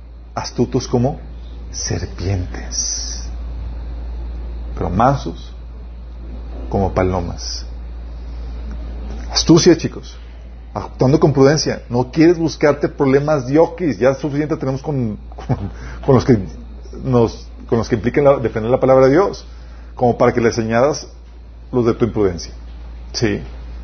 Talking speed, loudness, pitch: 115 wpm, -17 LUFS, 80 Hz